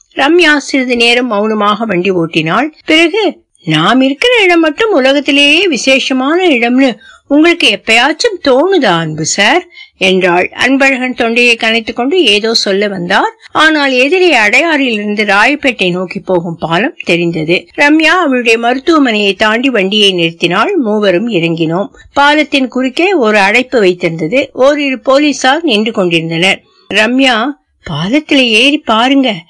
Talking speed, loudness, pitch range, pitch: 115 wpm, -9 LUFS, 200-295 Hz, 250 Hz